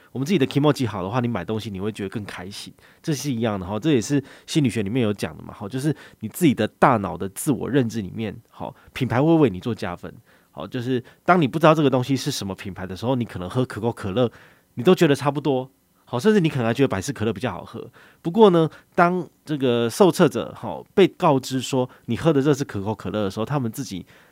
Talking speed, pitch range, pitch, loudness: 365 characters per minute, 105-145 Hz, 125 Hz, -22 LUFS